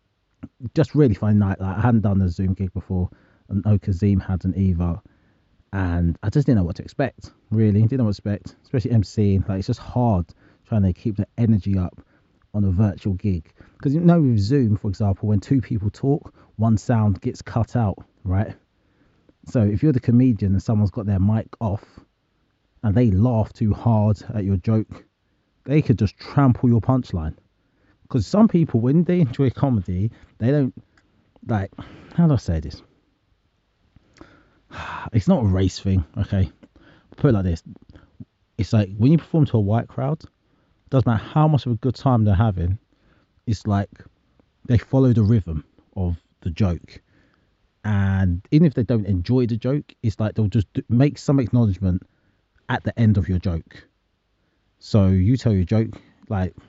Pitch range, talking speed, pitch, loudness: 95-120 Hz, 180 wpm, 105 Hz, -21 LUFS